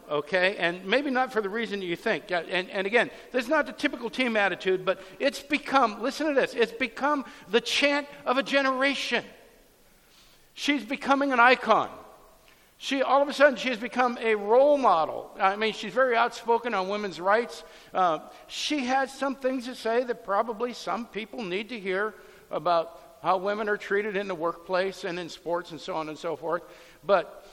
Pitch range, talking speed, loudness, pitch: 190-265 Hz, 190 wpm, -26 LUFS, 230 Hz